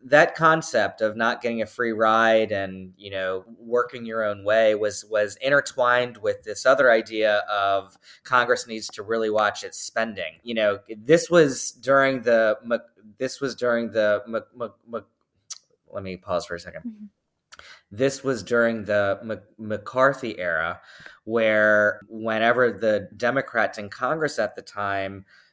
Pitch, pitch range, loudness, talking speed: 110 Hz, 105-125 Hz, -23 LUFS, 155 wpm